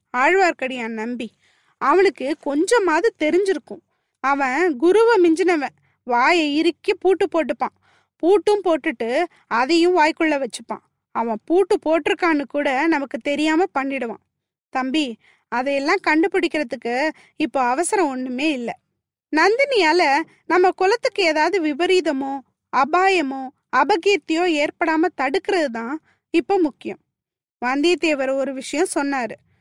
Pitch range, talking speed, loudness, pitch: 275-360 Hz, 95 wpm, -19 LUFS, 315 Hz